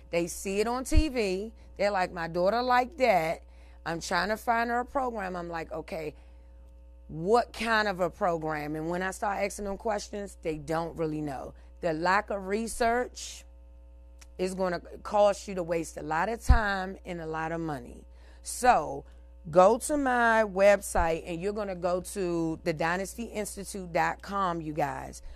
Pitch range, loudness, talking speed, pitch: 155-205 Hz, -29 LUFS, 170 wpm, 180 Hz